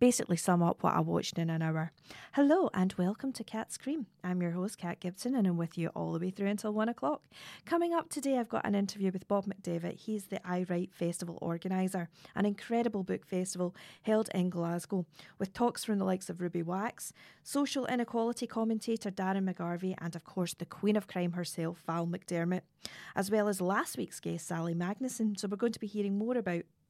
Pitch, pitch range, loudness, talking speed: 190 Hz, 175-220 Hz, -34 LUFS, 205 wpm